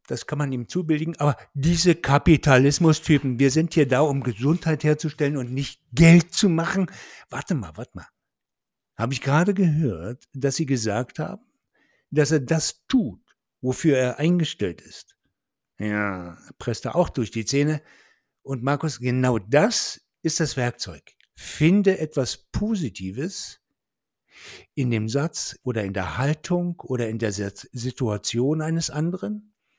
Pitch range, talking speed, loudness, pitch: 125-165 Hz, 145 wpm, -23 LUFS, 145 Hz